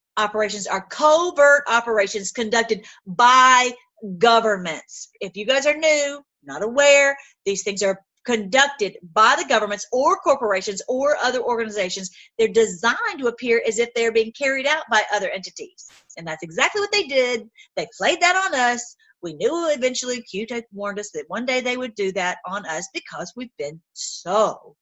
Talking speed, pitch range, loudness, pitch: 165 wpm, 205-280 Hz, -20 LUFS, 235 Hz